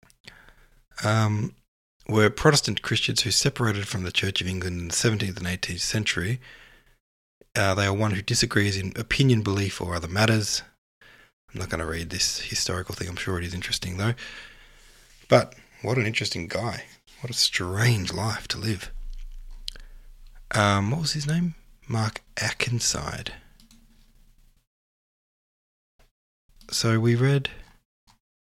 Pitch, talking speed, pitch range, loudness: 105 Hz, 135 wpm, 95-115 Hz, -25 LUFS